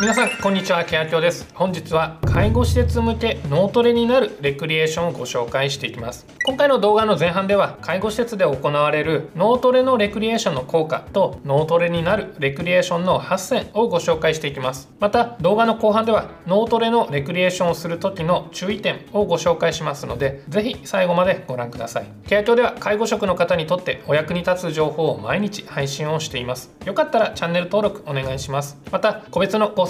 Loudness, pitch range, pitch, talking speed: -20 LUFS, 150-205 Hz, 175 Hz, 430 characters per minute